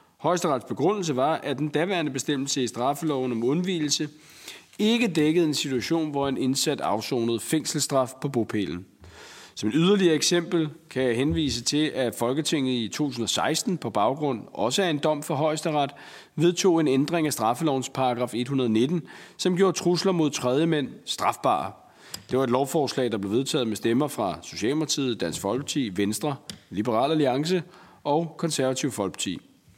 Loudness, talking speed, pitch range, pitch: -25 LUFS, 150 wpm, 130-160 Hz, 145 Hz